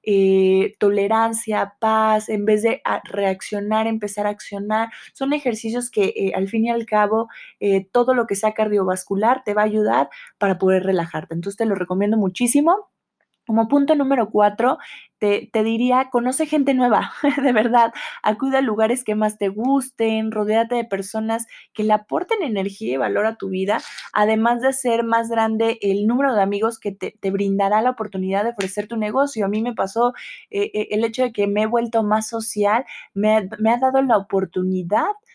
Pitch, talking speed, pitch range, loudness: 220 Hz, 180 wpm, 205-235 Hz, -20 LUFS